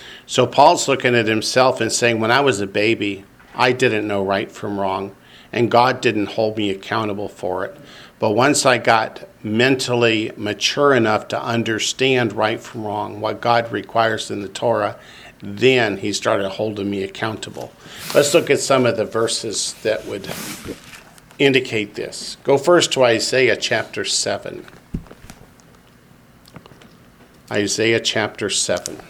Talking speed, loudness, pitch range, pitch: 145 wpm, -18 LUFS, 105-125 Hz, 115 Hz